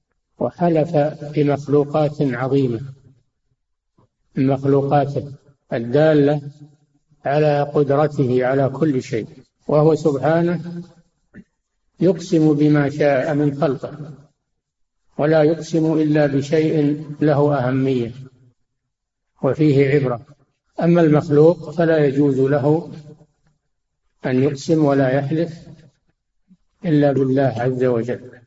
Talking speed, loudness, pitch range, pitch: 80 wpm, -18 LUFS, 135-155 Hz, 145 Hz